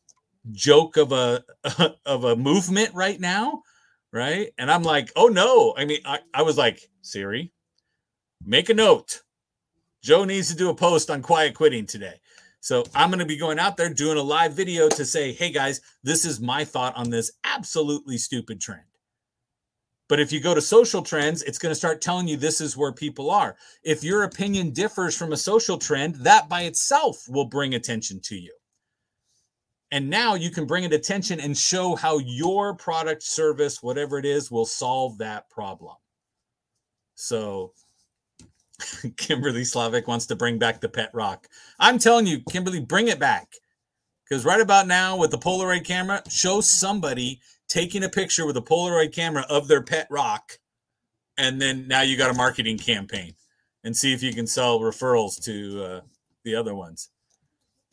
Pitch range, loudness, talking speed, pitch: 125-180 Hz, -22 LUFS, 175 wpm, 155 Hz